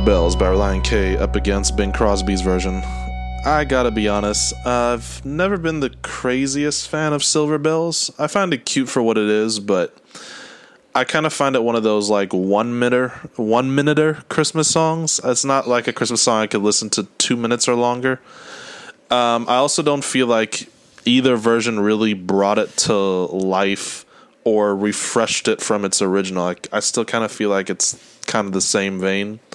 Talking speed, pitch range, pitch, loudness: 185 wpm, 100-135 Hz, 120 Hz, -18 LUFS